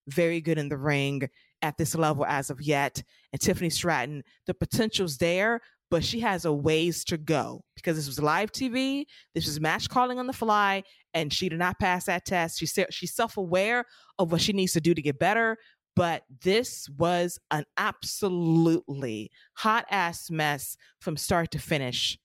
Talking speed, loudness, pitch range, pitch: 185 wpm, -27 LUFS, 150-190 Hz, 170 Hz